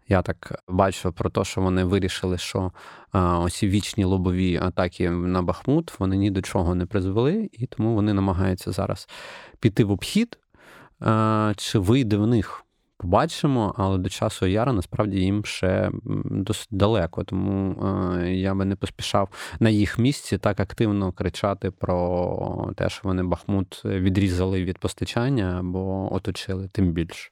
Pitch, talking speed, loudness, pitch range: 95 Hz, 150 wpm, -24 LUFS, 95-105 Hz